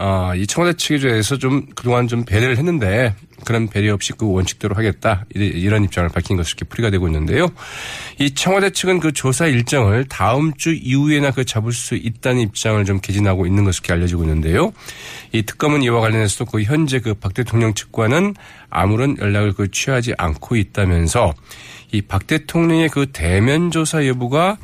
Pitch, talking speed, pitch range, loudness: 115 Hz, 375 characters per minute, 100-140 Hz, -17 LUFS